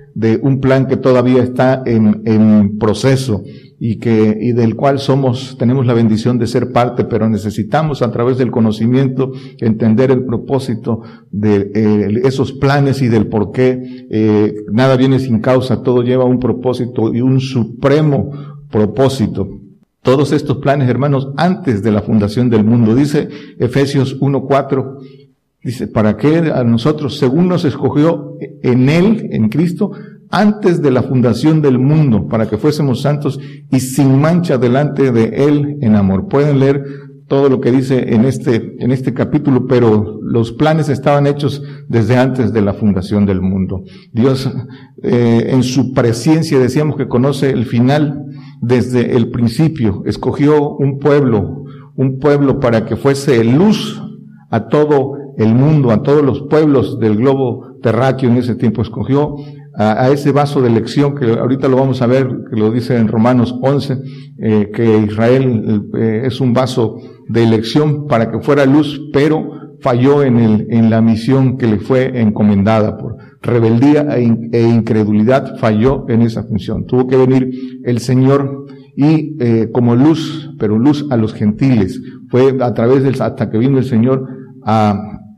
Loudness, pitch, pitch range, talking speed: -13 LUFS, 130 Hz, 115-140 Hz, 160 wpm